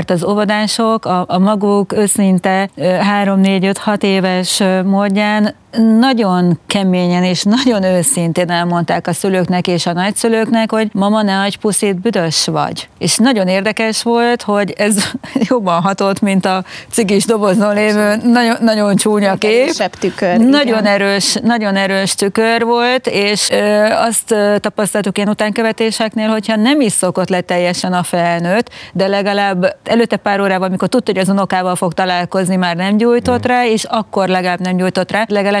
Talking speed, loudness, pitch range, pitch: 145 wpm, -13 LUFS, 185-220 Hz, 205 Hz